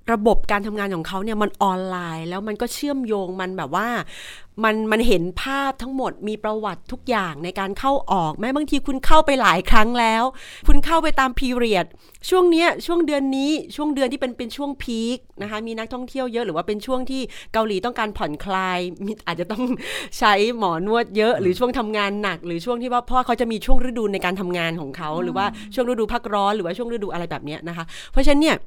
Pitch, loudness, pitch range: 220 Hz, -22 LUFS, 195-255 Hz